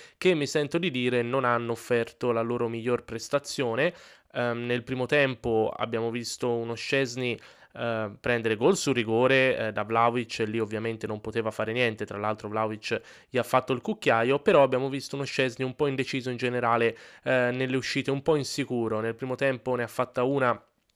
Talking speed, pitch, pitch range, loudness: 190 wpm, 120 Hz, 115-135 Hz, -27 LUFS